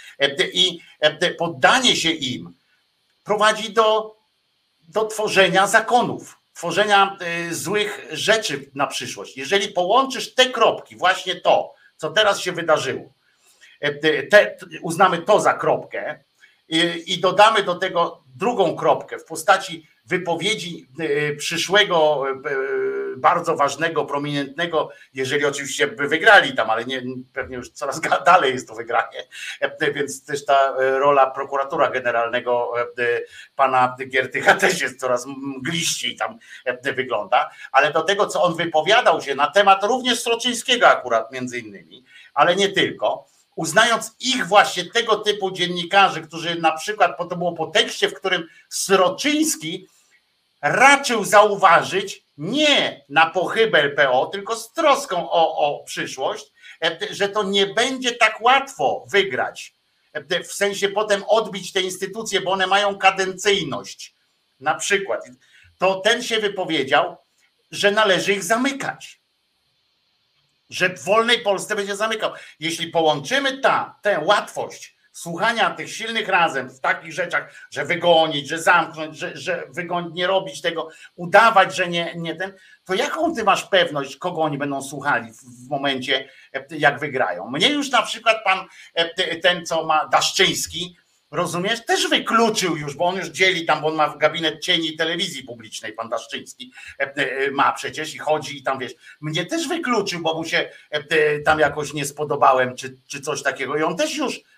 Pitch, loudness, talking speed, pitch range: 180 Hz, -20 LUFS, 140 wpm, 155-210 Hz